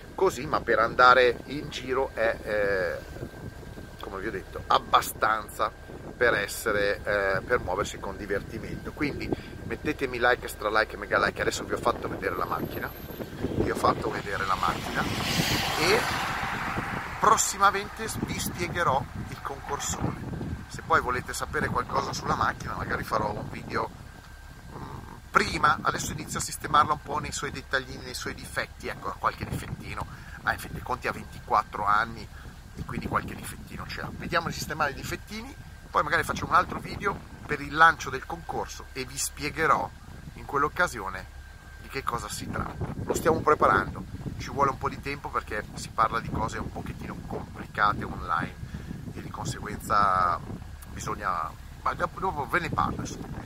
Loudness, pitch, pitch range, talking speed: -28 LUFS, 115 Hz, 100-140 Hz, 160 wpm